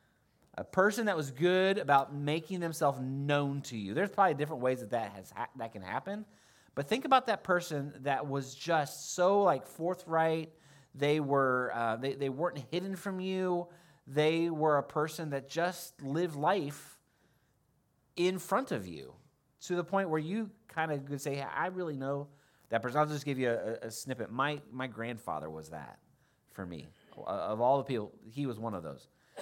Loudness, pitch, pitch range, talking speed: -33 LUFS, 145 Hz, 135-175 Hz, 190 wpm